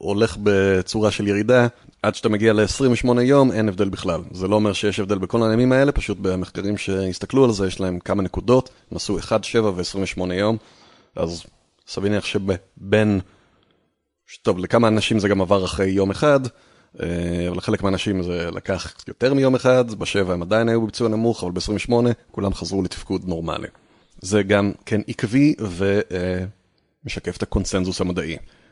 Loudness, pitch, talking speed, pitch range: -21 LUFS, 100 Hz, 155 wpm, 95-115 Hz